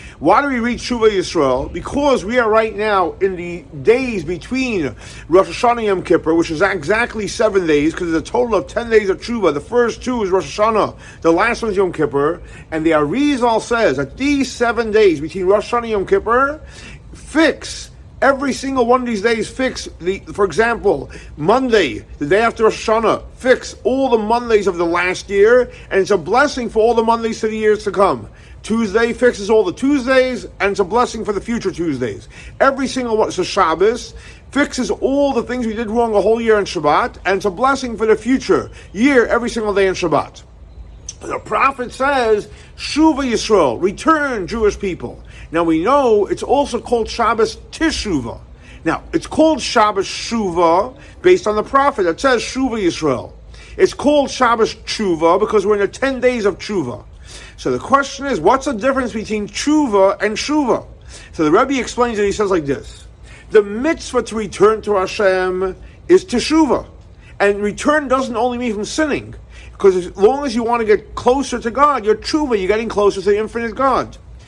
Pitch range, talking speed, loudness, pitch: 200-265 Hz, 190 wpm, -16 LUFS, 230 Hz